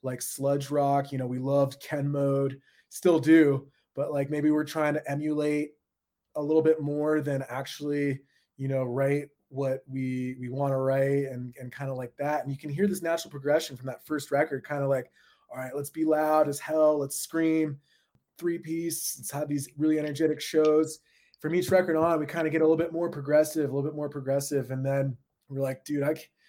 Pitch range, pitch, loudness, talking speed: 135-155 Hz, 145 Hz, -28 LUFS, 215 wpm